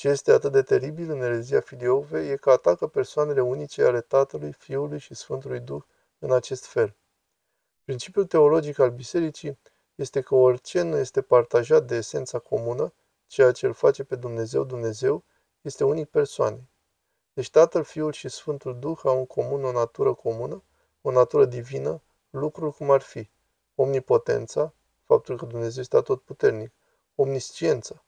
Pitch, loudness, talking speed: 150 Hz, -24 LUFS, 155 wpm